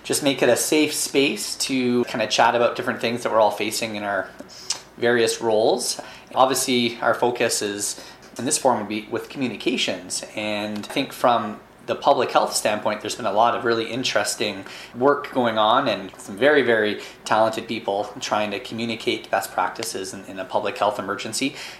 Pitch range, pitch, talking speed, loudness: 105-125 Hz, 115 Hz, 185 wpm, -22 LUFS